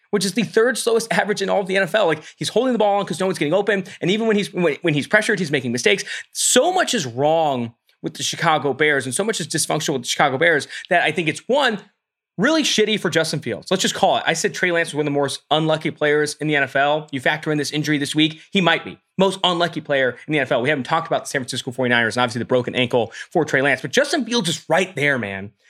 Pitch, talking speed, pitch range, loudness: 160 Hz, 275 wpm, 145-200 Hz, -19 LUFS